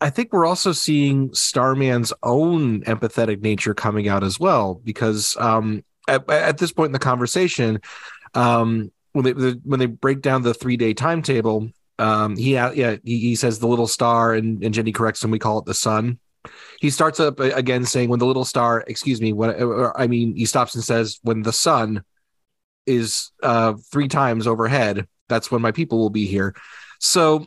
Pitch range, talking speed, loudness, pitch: 110-135 Hz, 190 wpm, -20 LUFS, 120 Hz